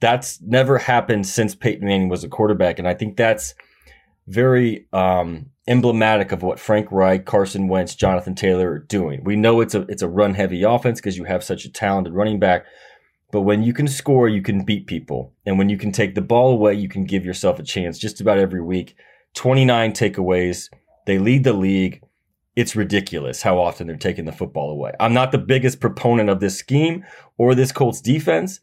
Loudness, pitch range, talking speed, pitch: -19 LUFS, 95-120 Hz, 205 wpm, 105 Hz